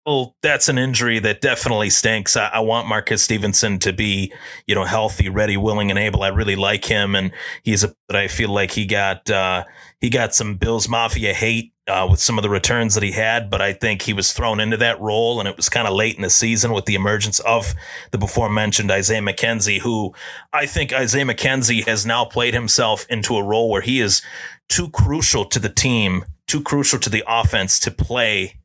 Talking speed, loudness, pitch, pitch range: 220 wpm, -17 LUFS, 110 Hz, 100-115 Hz